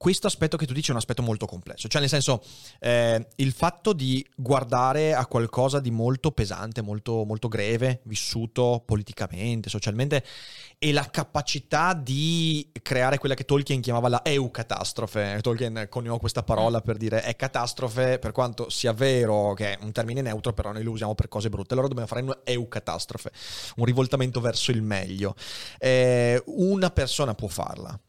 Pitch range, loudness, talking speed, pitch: 110-135 Hz, -26 LUFS, 170 wpm, 120 Hz